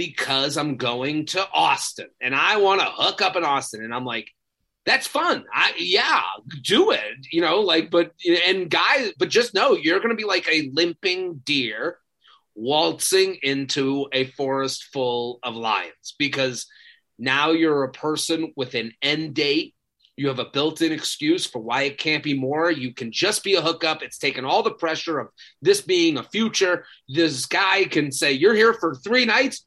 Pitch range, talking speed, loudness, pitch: 135-195 Hz, 180 wpm, -21 LUFS, 160 Hz